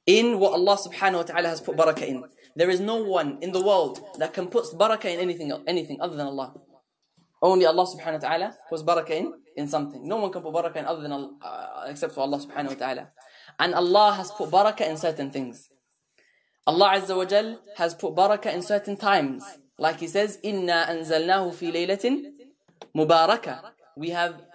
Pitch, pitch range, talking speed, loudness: 175 Hz, 160-200 Hz, 195 wpm, -24 LUFS